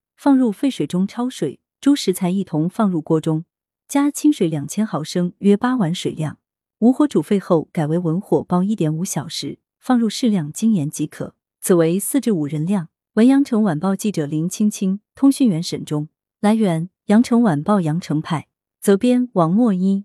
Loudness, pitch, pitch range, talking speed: -19 LUFS, 190 Hz, 160-225 Hz, 260 characters per minute